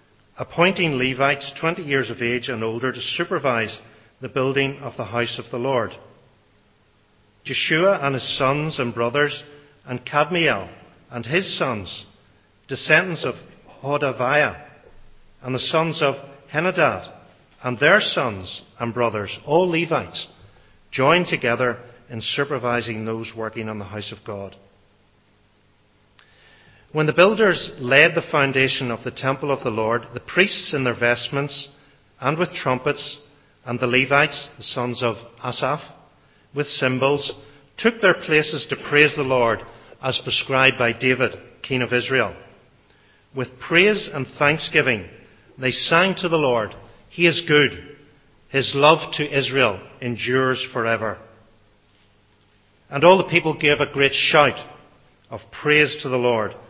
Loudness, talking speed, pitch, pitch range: -20 LUFS, 135 wpm, 130 Hz, 115-145 Hz